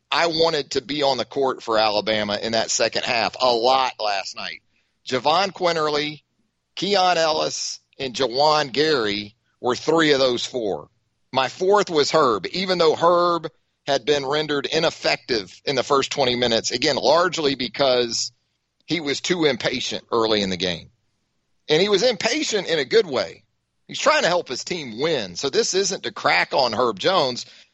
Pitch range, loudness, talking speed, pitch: 115-170 Hz, -21 LUFS, 170 wpm, 140 Hz